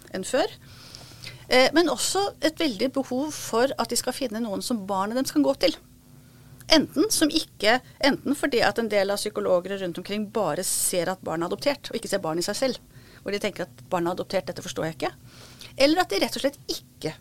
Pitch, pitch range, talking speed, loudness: 240 Hz, 195-280 Hz, 220 wpm, -25 LUFS